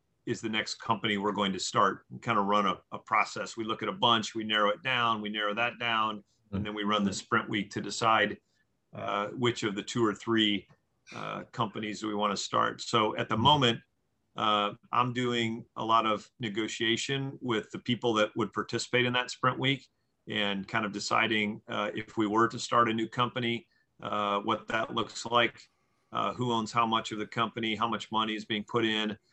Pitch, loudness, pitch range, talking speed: 110 Hz, -30 LUFS, 105-120 Hz, 215 wpm